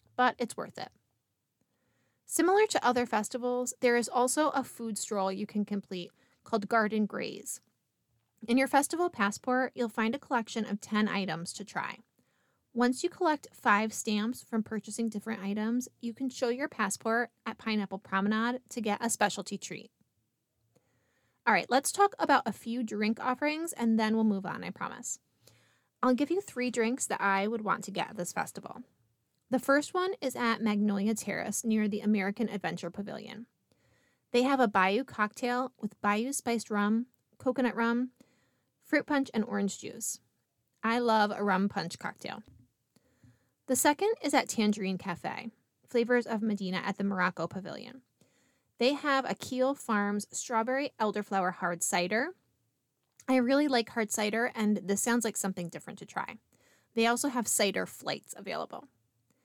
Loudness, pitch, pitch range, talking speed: -31 LUFS, 225 Hz, 200-250 Hz, 160 wpm